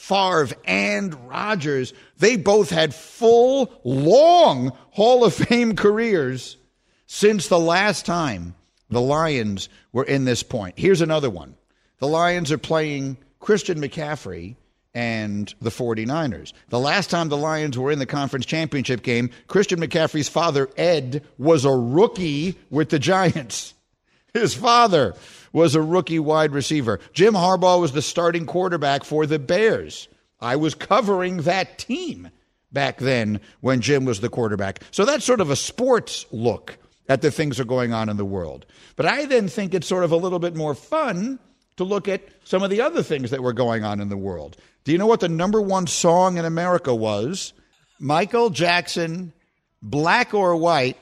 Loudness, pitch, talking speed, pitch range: -20 LUFS, 155 Hz, 170 wpm, 125-185 Hz